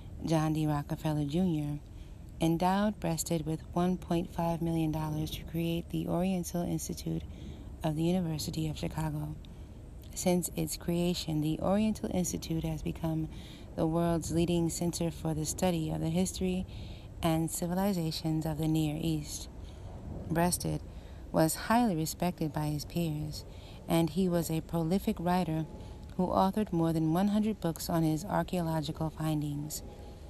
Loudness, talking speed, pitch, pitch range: -32 LUFS, 130 wpm, 160 Hz, 155-175 Hz